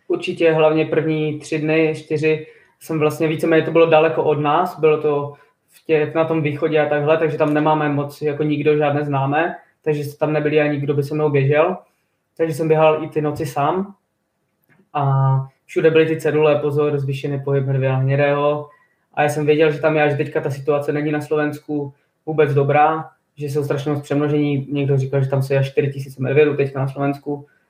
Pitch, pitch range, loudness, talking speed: 150 Hz, 145-155 Hz, -18 LUFS, 195 wpm